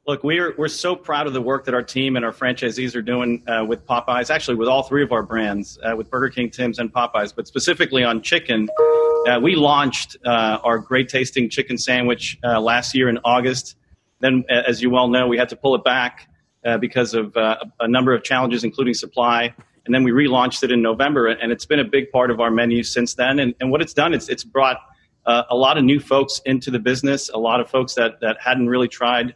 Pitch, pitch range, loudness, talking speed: 125 Hz, 120-135 Hz, -19 LUFS, 235 wpm